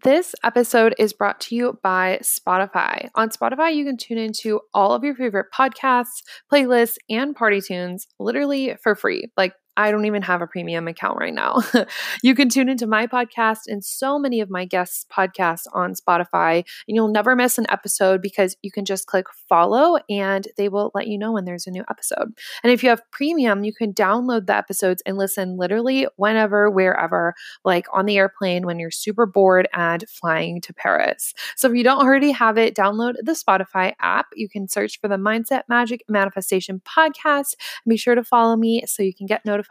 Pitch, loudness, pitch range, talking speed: 215 Hz, -20 LUFS, 190-245 Hz, 200 wpm